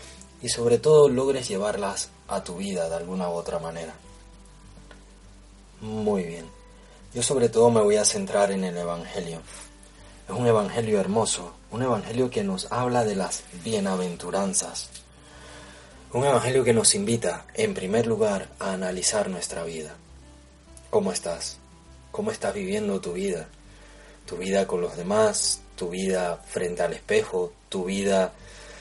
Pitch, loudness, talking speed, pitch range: 100 Hz, -25 LUFS, 140 wpm, 85-125 Hz